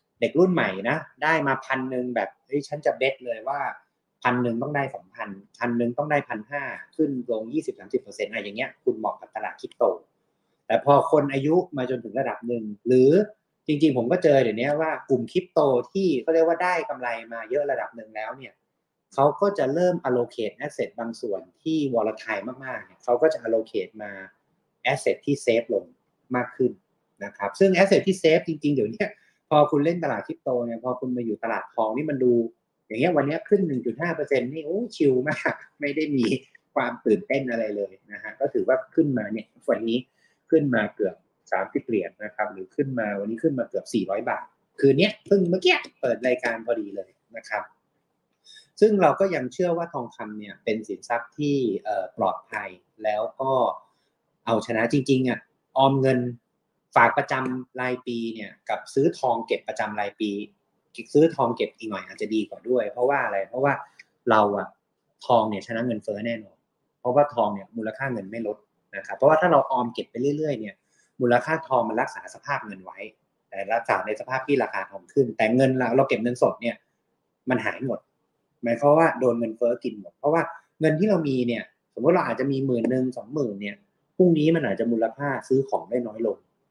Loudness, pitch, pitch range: -25 LUFS, 130 Hz, 115-155 Hz